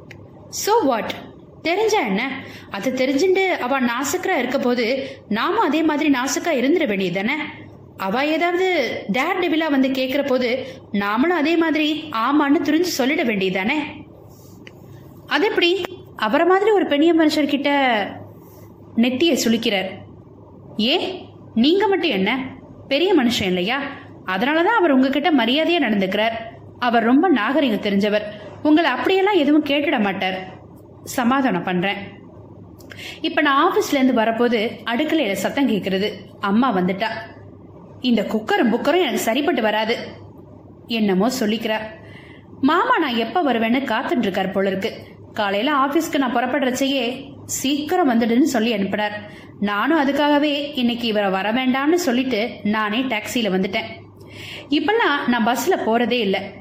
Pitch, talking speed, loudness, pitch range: 265 Hz, 70 wpm, -19 LUFS, 220-310 Hz